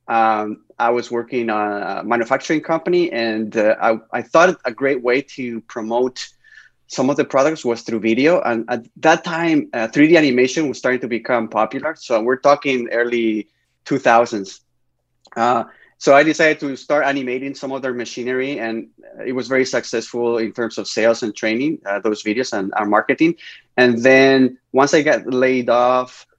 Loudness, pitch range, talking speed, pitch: -18 LUFS, 115-135 Hz, 175 wpm, 125 Hz